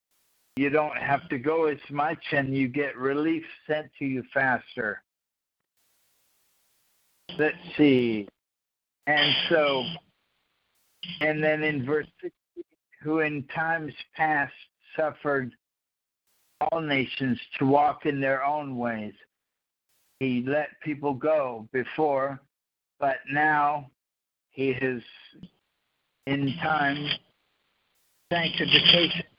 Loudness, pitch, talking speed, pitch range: -26 LUFS, 145 Hz, 100 wpm, 135-155 Hz